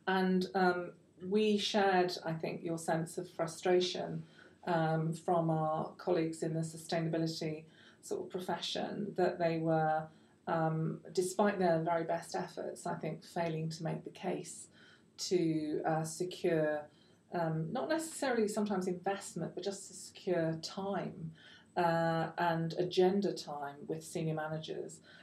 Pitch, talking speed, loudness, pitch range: 170 Hz, 135 wpm, -35 LUFS, 160-185 Hz